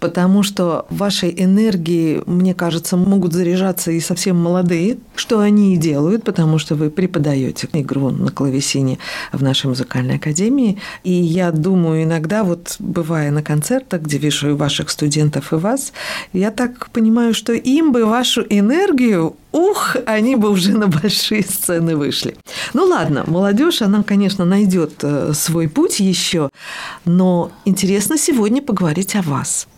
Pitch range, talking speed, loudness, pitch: 160-210 Hz, 145 wpm, -16 LUFS, 180 Hz